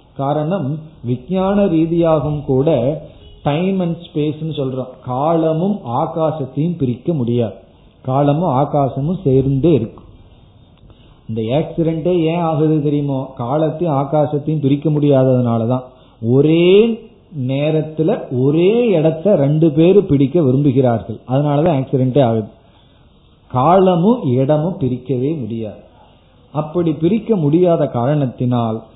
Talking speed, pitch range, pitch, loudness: 85 wpm, 130-160 Hz, 145 Hz, -16 LUFS